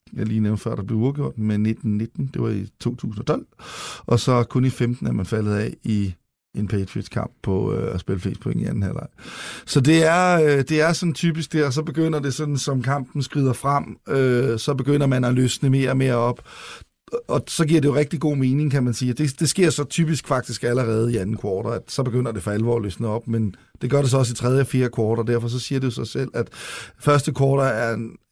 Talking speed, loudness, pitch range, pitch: 245 wpm, -22 LUFS, 115-145 Hz, 130 Hz